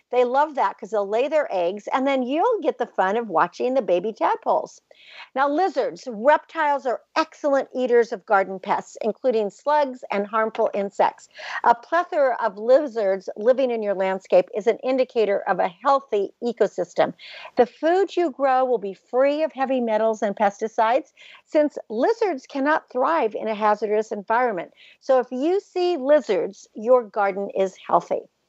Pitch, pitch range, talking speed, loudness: 250 Hz, 215-295 Hz, 160 wpm, -22 LUFS